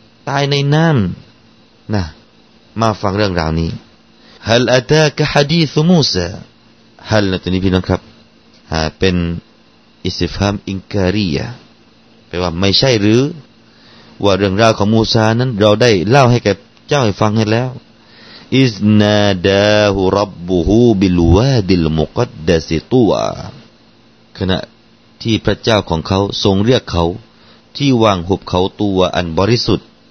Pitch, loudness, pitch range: 110 Hz, -14 LUFS, 95-115 Hz